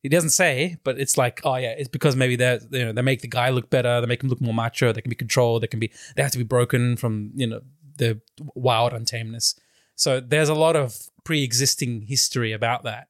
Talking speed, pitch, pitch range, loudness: 245 wpm, 125 Hz, 120-140 Hz, -22 LUFS